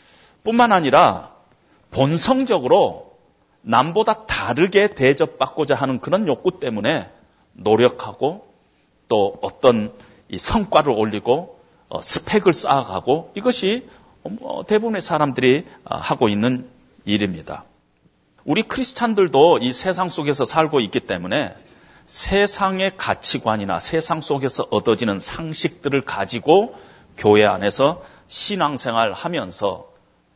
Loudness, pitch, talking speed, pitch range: -19 LUFS, 160 Hz, 250 characters per minute, 125-195 Hz